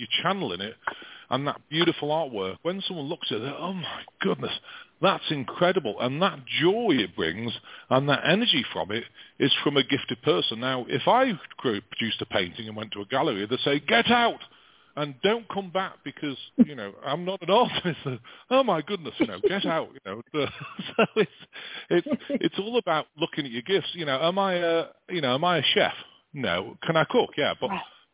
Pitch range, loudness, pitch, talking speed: 135-195 Hz, -26 LUFS, 165 Hz, 210 wpm